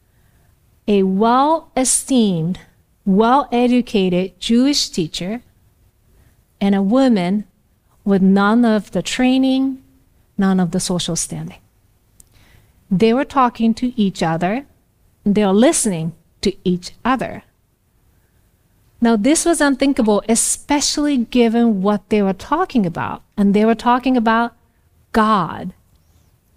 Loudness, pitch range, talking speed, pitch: -17 LUFS, 175-245 Hz, 115 wpm, 210 Hz